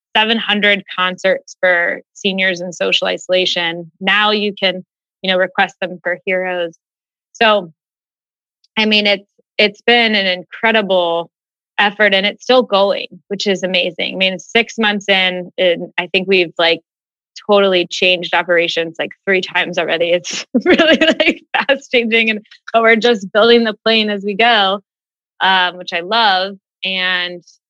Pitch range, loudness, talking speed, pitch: 180-215 Hz, -14 LUFS, 150 wpm, 190 Hz